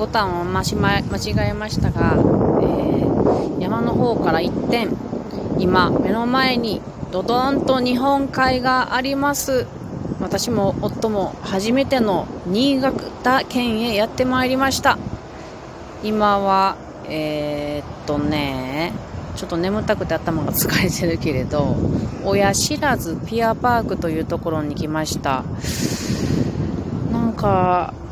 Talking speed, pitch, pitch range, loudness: 225 characters per minute, 210 Hz, 170-255 Hz, -20 LUFS